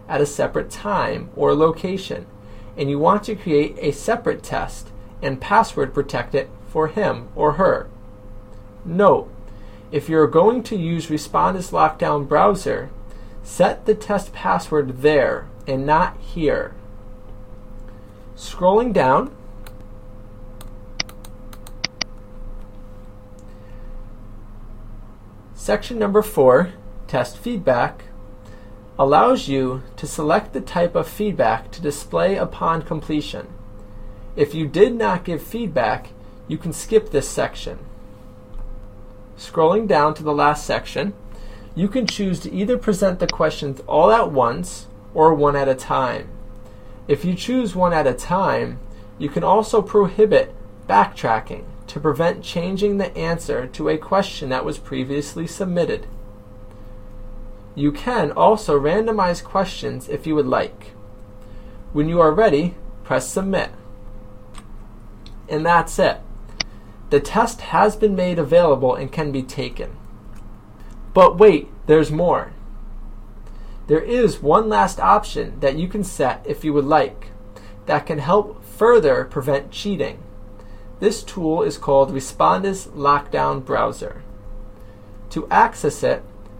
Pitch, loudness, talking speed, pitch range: 130 Hz, -19 LUFS, 125 wpm, 105-170 Hz